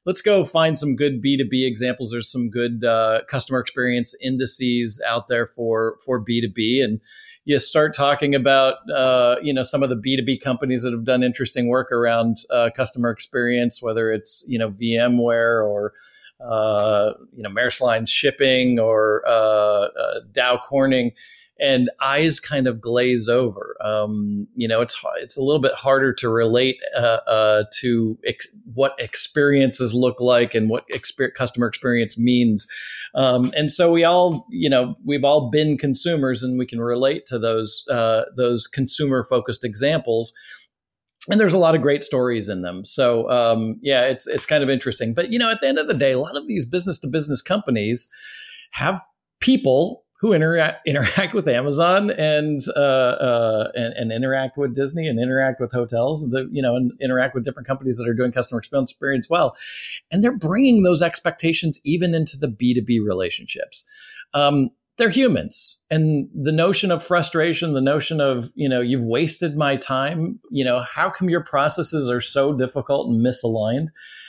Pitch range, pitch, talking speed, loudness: 120-150 Hz, 130 Hz, 180 wpm, -20 LUFS